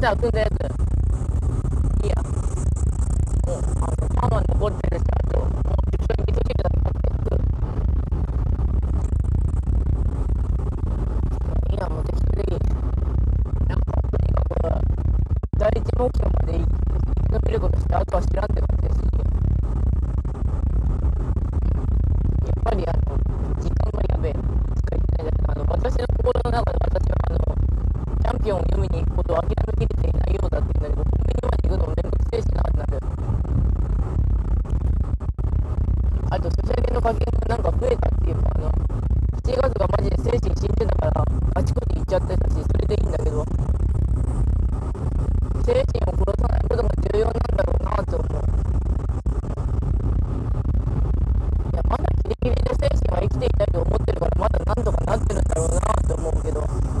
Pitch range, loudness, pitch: 75-90 Hz, -23 LUFS, 85 Hz